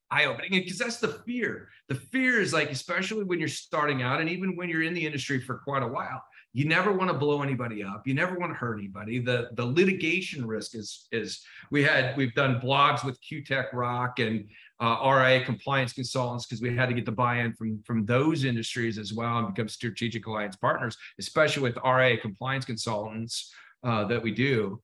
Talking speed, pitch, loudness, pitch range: 210 wpm, 130 Hz, -28 LUFS, 115-150 Hz